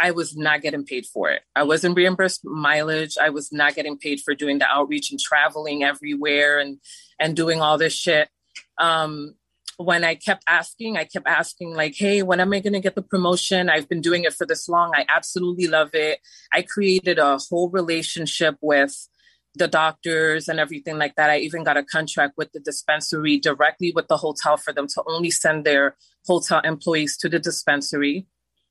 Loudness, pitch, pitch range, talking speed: -21 LUFS, 155 Hz, 150-175 Hz, 195 wpm